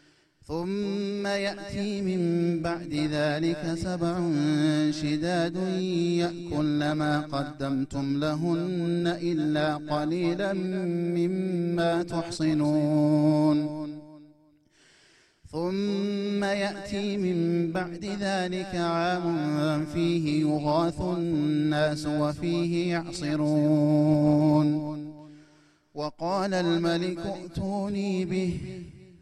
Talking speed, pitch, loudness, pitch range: 60 wpm, 170 Hz, -27 LUFS, 150-180 Hz